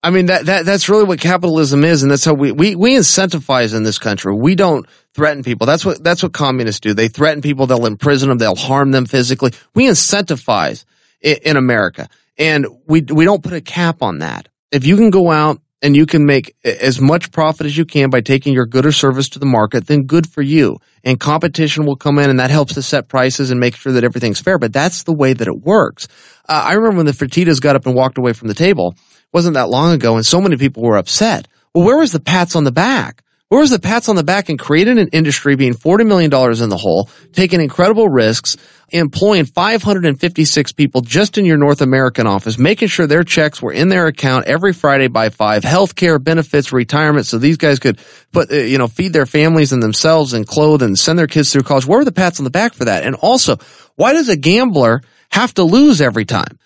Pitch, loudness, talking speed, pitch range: 150 Hz, -12 LUFS, 235 wpm, 130-170 Hz